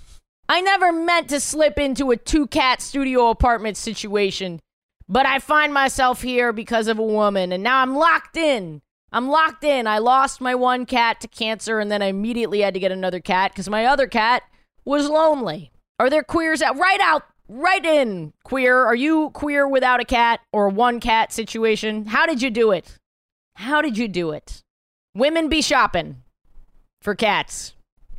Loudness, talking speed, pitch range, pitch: -19 LUFS, 185 wpm, 215-290 Hz, 245 Hz